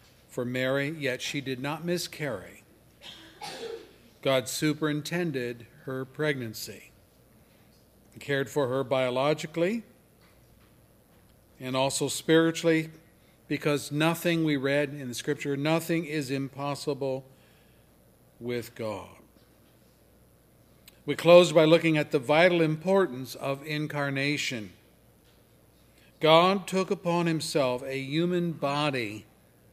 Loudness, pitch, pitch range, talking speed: -27 LUFS, 145 Hz, 130-165 Hz, 95 wpm